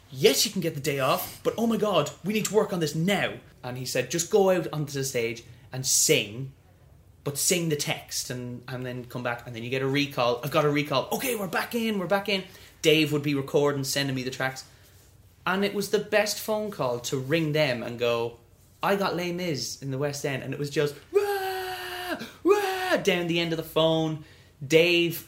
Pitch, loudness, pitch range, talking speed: 150 Hz, -26 LUFS, 130-190 Hz, 230 wpm